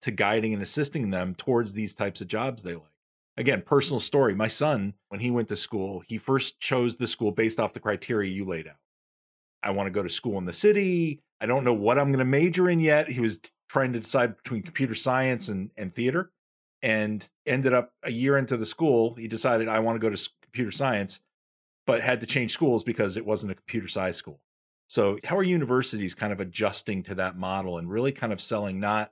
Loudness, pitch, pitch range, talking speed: -26 LUFS, 115 Hz, 100-130 Hz, 225 wpm